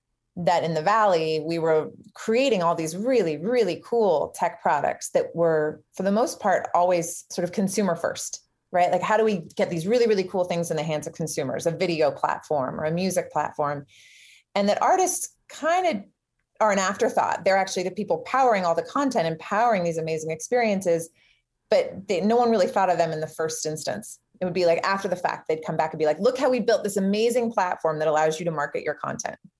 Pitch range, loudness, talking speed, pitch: 160-220 Hz, -24 LUFS, 220 wpm, 180 Hz